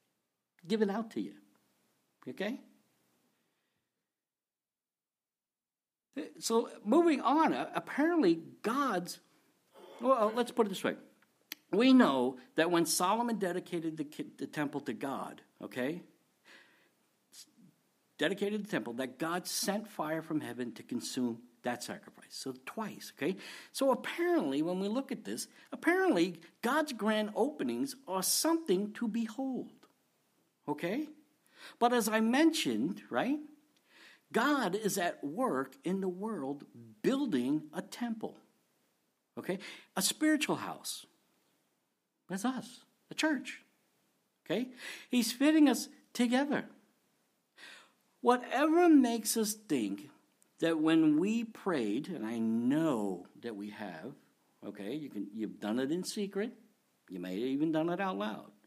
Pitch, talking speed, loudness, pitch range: 220 Hz, 120 wpm, -33 LUFS, 160-265 Hz